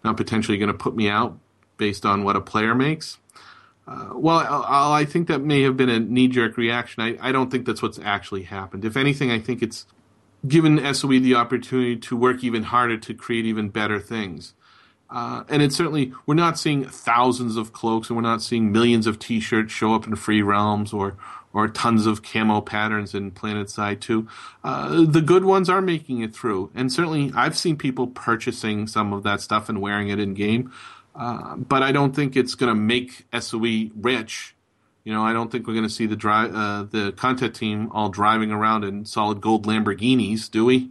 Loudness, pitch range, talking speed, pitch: -22 LUFS, 105-130 Hz, 215 wpm, 115 Hz